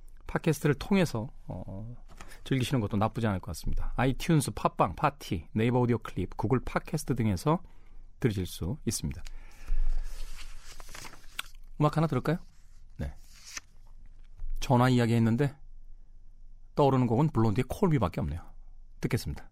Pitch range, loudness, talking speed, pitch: 95-130 Hz, -30 LUFS, 295 characters per minute, 110 Hz